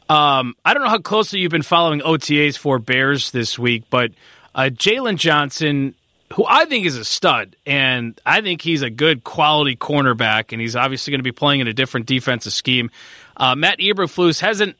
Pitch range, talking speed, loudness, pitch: 125-165 Hz, 195 wpm, -17 LUFS, 140 Hz